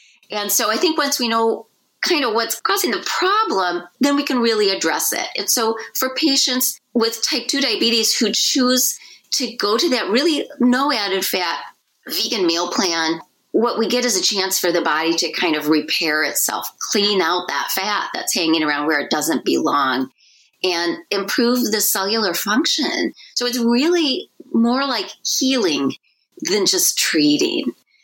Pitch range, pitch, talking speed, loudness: 190-275 Hz, 230 Hz, 170 wpm, -18 LUFS